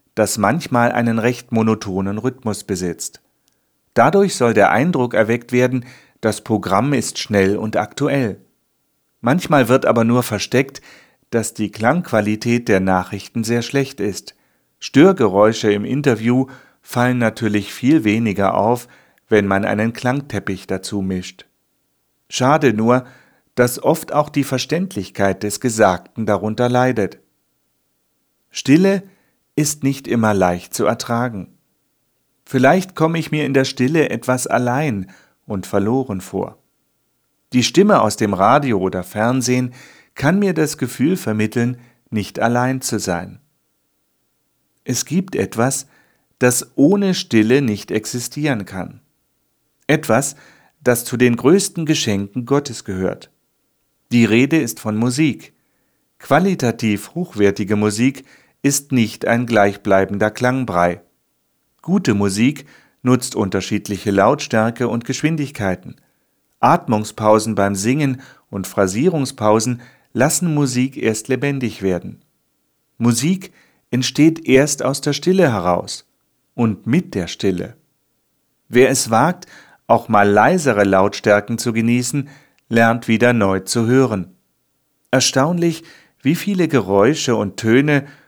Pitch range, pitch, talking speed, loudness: 105-135 Hz, 120 Hz, 115 wpm, -17 LUFS